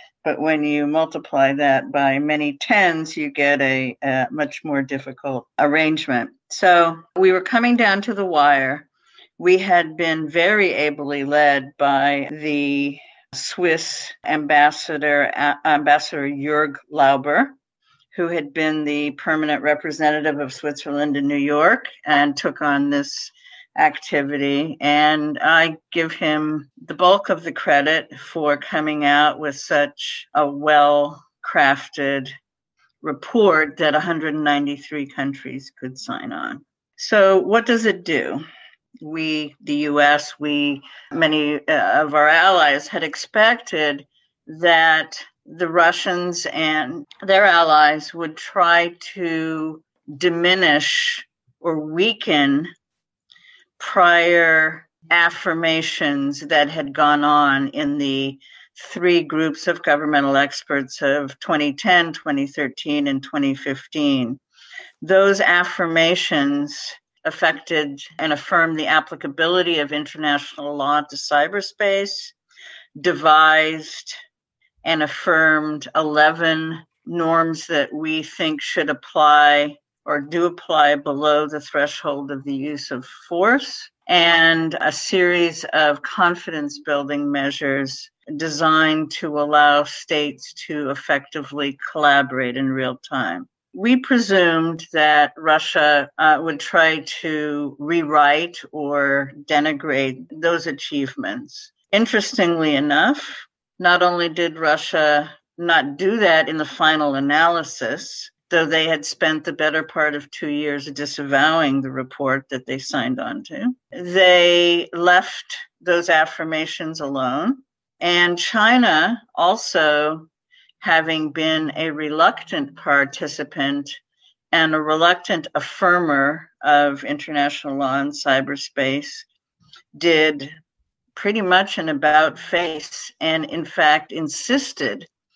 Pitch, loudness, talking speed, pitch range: 155 Hz, -18 LUFS, 110 wpm, 145-175 Hz